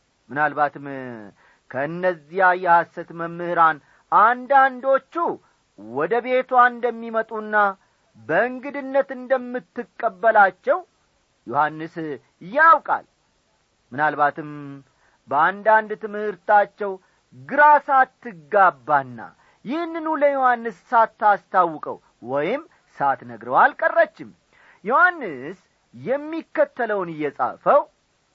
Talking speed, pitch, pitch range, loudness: 55 wpm, 215 Hz, 170-265 Hz, -20 LUFS